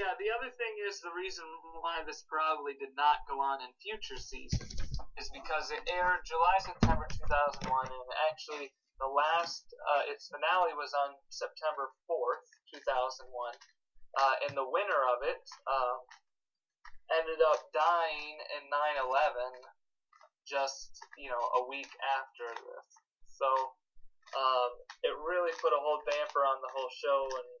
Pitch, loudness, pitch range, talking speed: 150 Hz, -34 LUFS, 135-180 Hz, 150 wpm